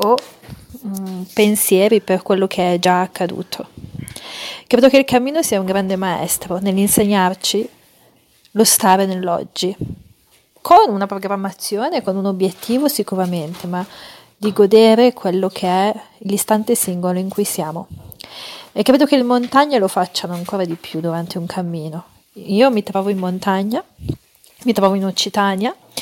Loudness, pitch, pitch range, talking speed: -16 LUFS, 195 Hz, 185-215 Hz, 140 wpm